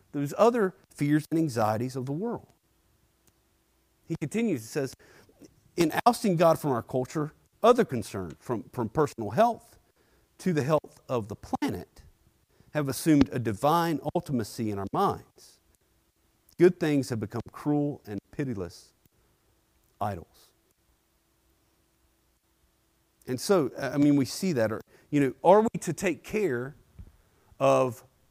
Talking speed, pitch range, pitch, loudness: 130 wpm, 110-155 Hz, 135 Hz, -28 LUFS